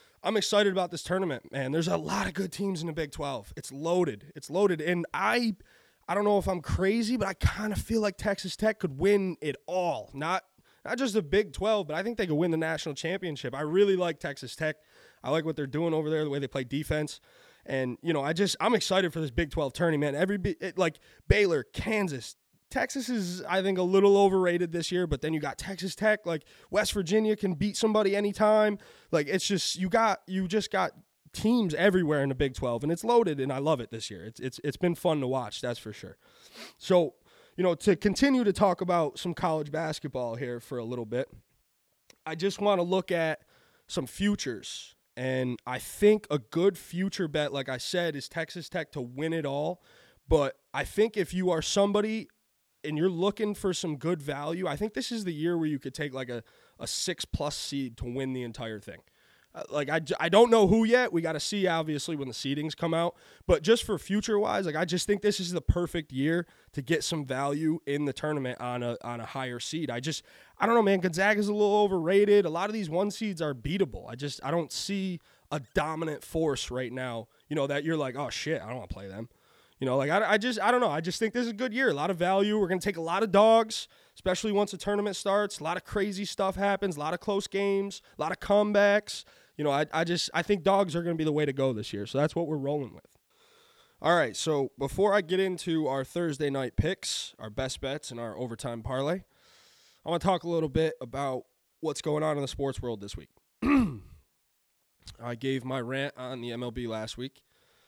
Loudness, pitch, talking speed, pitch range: -29 LUFS, 170 Hz, 235 wpm, 140-200 Hz